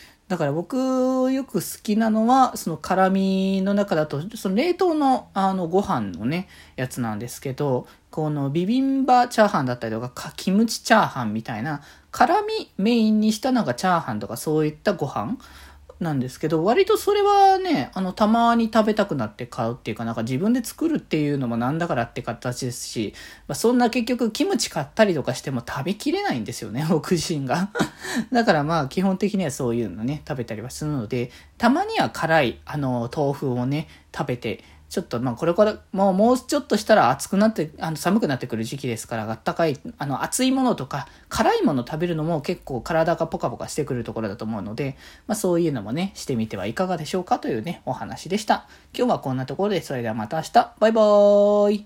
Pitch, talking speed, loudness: 170 Hz, 415 characters per minute, -23 LUFS